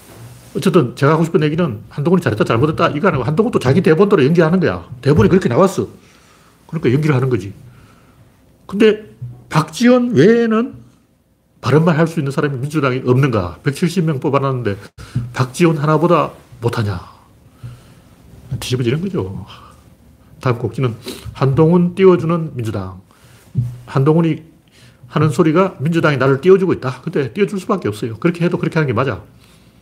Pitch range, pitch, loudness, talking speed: 125-175 Hz, 145 Hz, -16 LUFS, 345 characters per minute